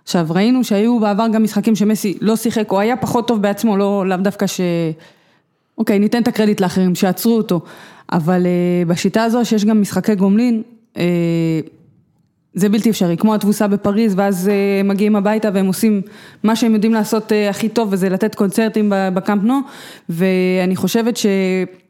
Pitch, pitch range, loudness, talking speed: 205 Hz, 185-220 Hz, -16 LUFS, 155 wpm